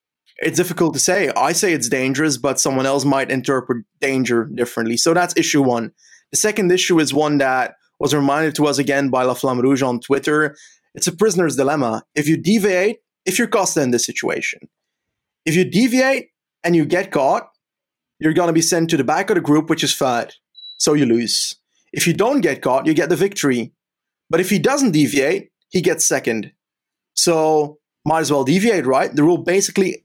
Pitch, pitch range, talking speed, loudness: 155 Hz, 135-175 Hz, 200 wpm, -17 LUFS